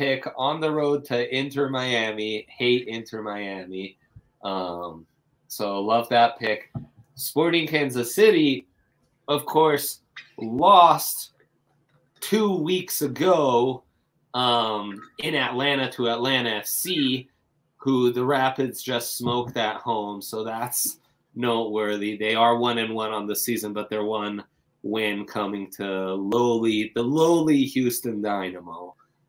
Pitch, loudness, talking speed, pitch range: 120 Hz, -23 LUFS, 120 wpm, 105-130 Hz